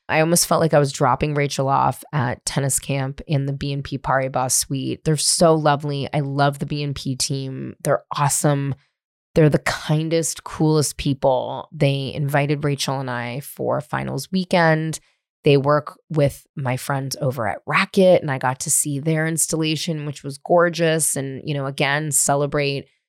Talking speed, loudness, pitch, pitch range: 165 wpm, -20 LUFS, 145 Hz, 135-155 Hz